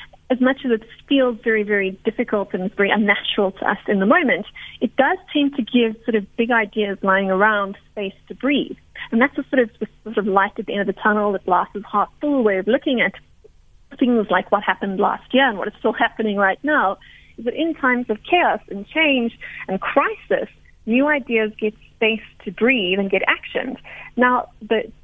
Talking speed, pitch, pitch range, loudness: 210 wpm, 220 Hz, 205-255 Hz, -20 LUFS